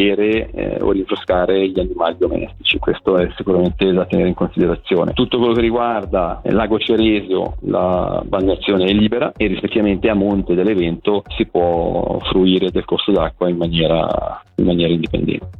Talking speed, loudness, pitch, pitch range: 150 wpm, -17 LUFS, 95 Hz, 90-110 Hz